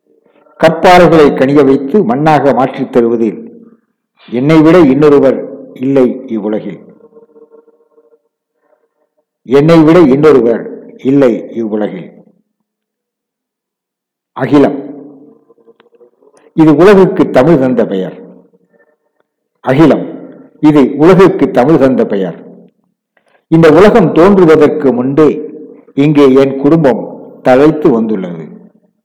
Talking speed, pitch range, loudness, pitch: 75 wpm, 135-220 Hz, -8 LUFS, 155 Hz